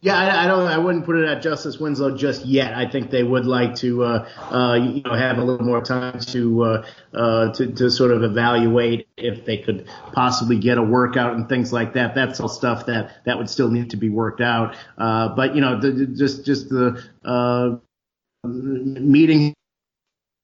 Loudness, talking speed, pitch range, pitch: -20 LUFS, 200 wpm, 120-135 Hz, 125 Hz